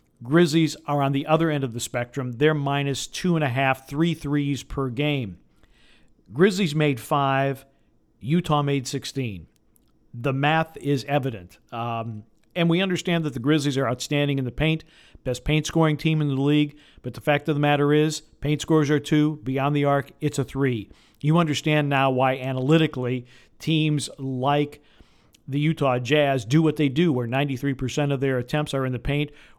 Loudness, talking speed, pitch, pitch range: -23 LUFS, 180 wpm, 140 Hz, 130-150 Hz